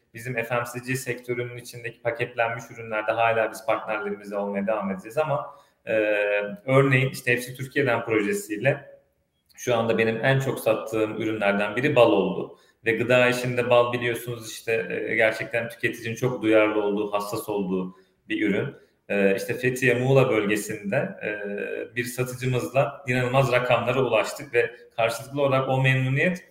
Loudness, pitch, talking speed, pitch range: -24 LUFS, 120 Hz, 140 wpm, 110-125 Hz